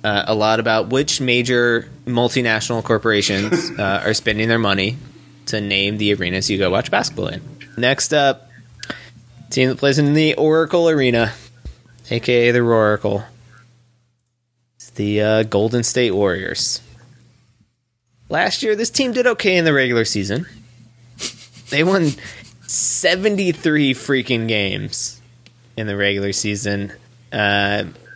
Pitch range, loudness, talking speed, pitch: 110-130 Hz, -17 LUFS, 130 wpm, 120 Hz